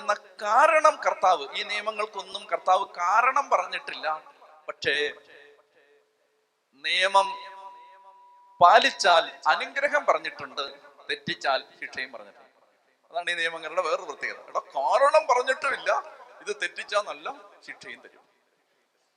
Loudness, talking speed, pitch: -25 LUFS, 90 wpm, 255 Hz